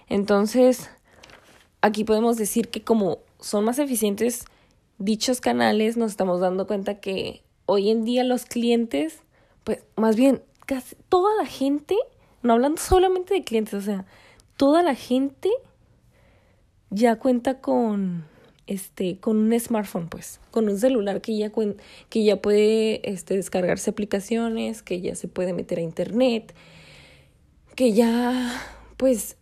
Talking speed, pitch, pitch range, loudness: 135 wpm, 225 Hz, 205-255 Hz, -23 LUFS